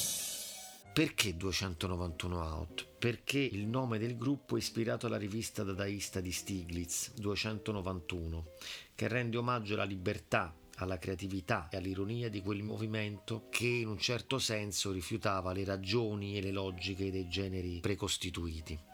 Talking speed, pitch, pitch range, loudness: 135 wpm, 100 Hz, 95-110 Hz, -37 LUFS